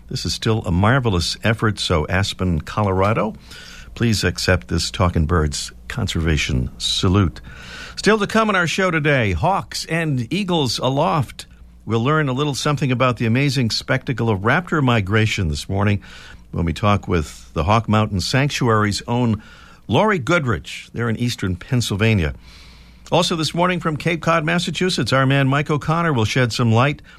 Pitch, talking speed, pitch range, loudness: 115 Hz, 155 wpm, 95-145 Hz, -19 LUFS